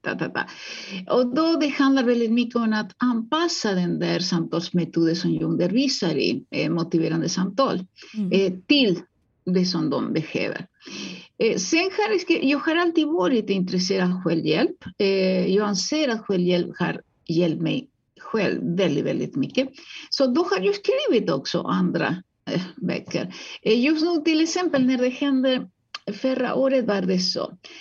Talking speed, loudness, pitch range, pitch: 150 wpm, -23 LUFS, 185-290 Hz, 230 Hz